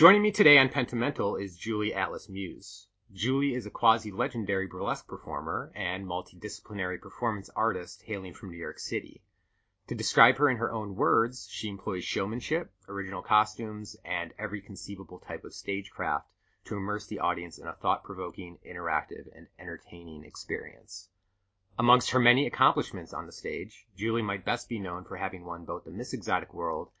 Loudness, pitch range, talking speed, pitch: -30 LUFS, 95-115 Hz, 160 wpm, 100 Hz